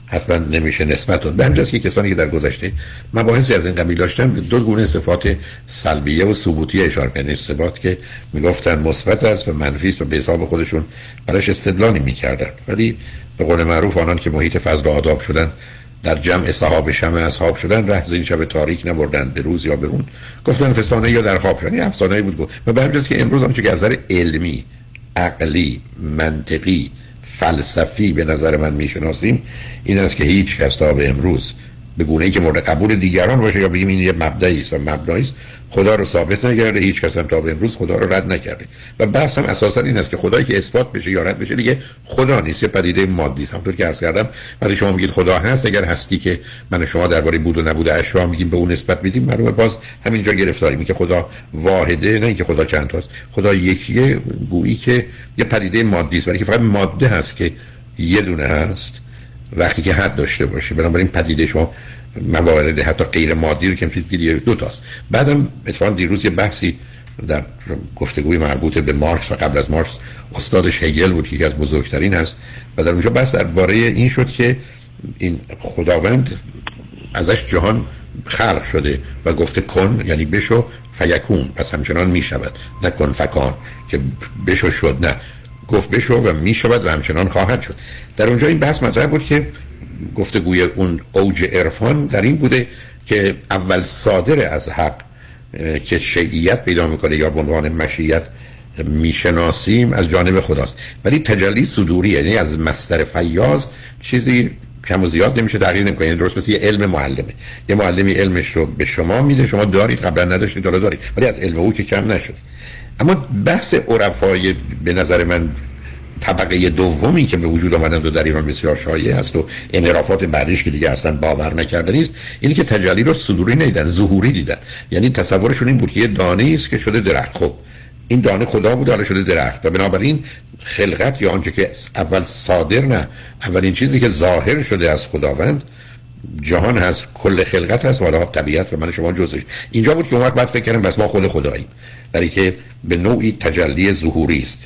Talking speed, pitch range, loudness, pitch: 185 wpm, 80-115 Hz, -16 LUFS, 95 Hz